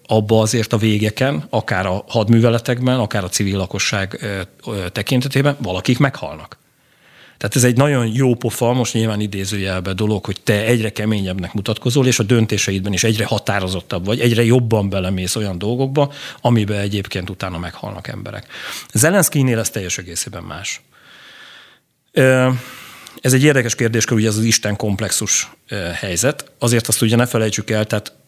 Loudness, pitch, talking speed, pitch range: -17 LUFS, 110 Hz, 145 wpm, 100-125 Hz